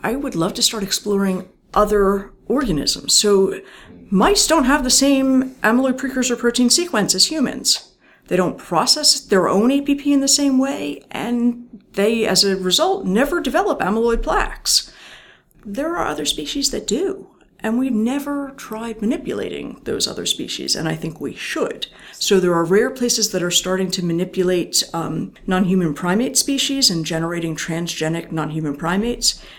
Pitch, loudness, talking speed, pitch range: 225 Hz, -18 LUFS, 160 wpm, 185-270 Hz